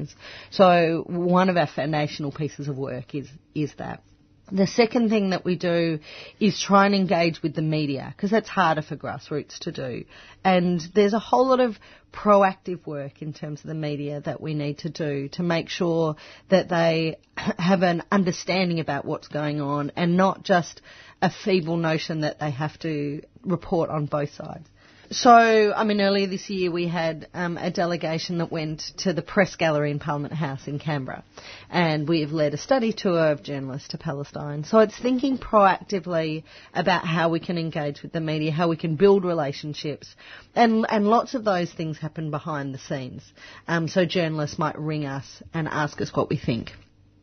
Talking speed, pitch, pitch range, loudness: 185 wpm, 165 Hz, 150-185 Hz, -24 LUFS